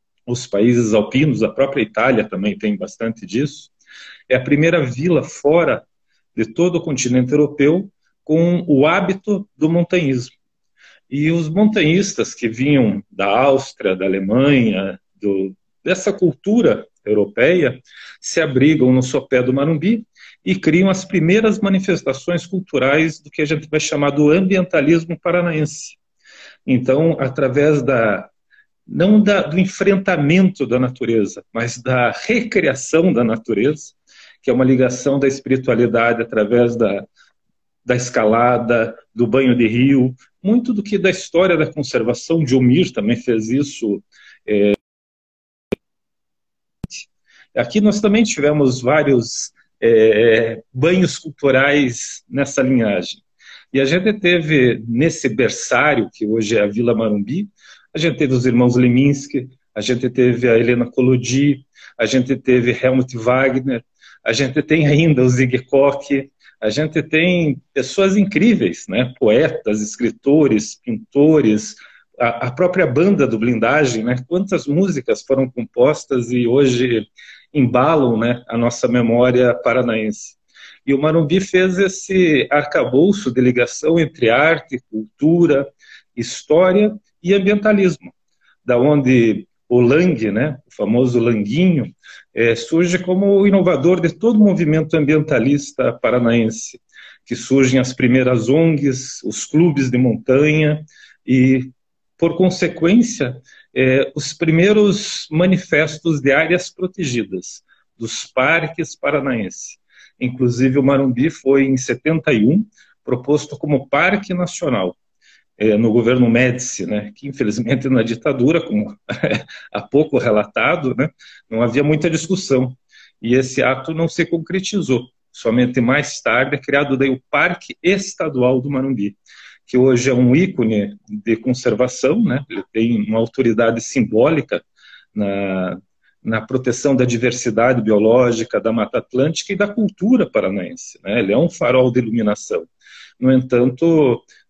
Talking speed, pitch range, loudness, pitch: 125 wpm, 125-170 Hz, -16 LUFS, 135 Hz